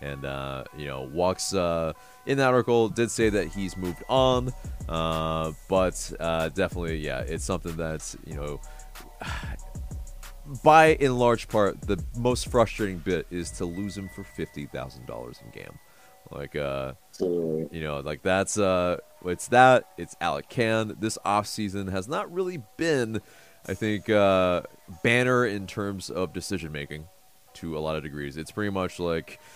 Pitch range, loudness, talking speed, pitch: 80-110 Hz, -26 LUFS, 160 wpm, 95 Hz